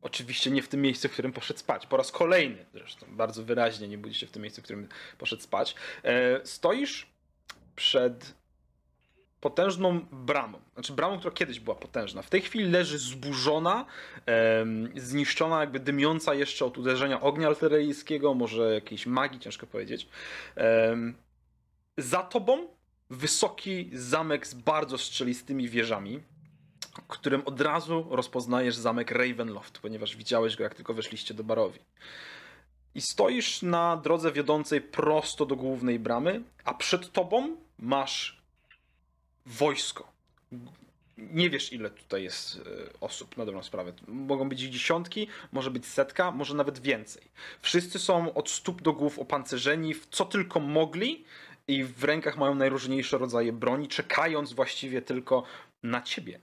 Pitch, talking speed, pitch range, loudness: 140 Hz, 140 wpm, 120-155 Hz, -29 LUFS